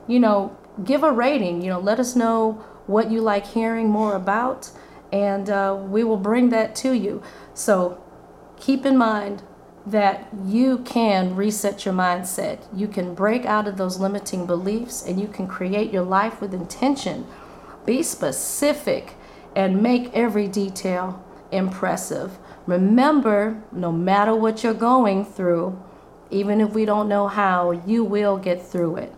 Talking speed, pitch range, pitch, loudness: 155 wpm, 190-225 Hz, 205 Hz, -21 LUFS